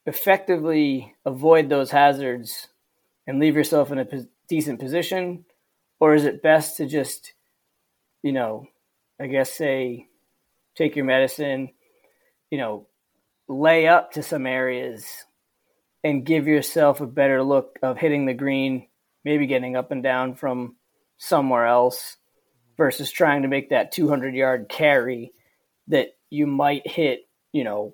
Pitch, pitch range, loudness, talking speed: 140 Hz, 130-155 Hz, -22 LUFS, 140 wpm